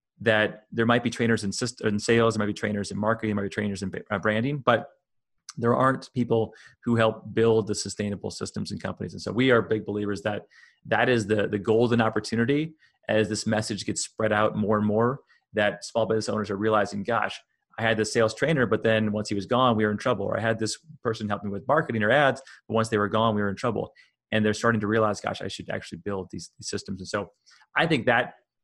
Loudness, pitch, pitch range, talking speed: -26 LUFS, 110 Hz, 105-115 Hz, 235 wpm